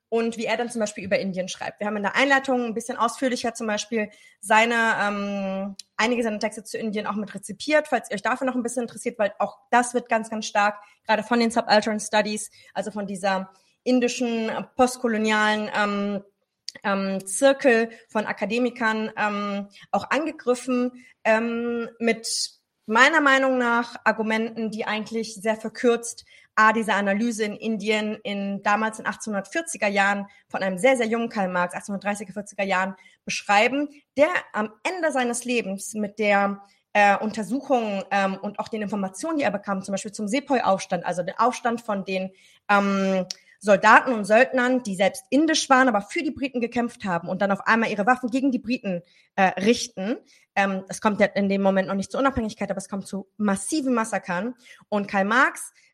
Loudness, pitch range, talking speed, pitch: -23 LUFS, 200-240 Hz, 180 wpm, 215 Hz